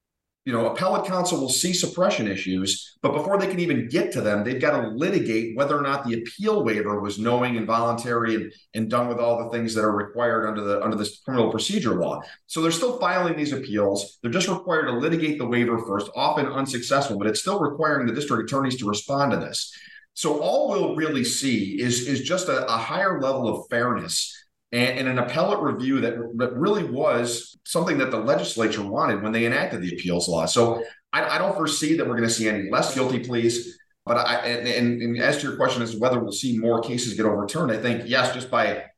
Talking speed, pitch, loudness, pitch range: 225 wpm, 120 Hz, -24 LUFS, 110-140 Hz